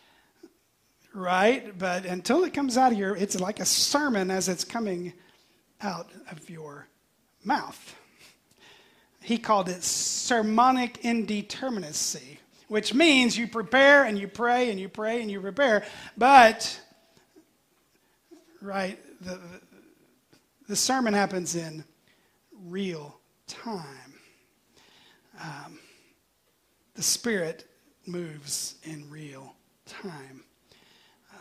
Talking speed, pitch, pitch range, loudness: 100 wpm, 200 Hz, 180-240 Hz, -25 LUFS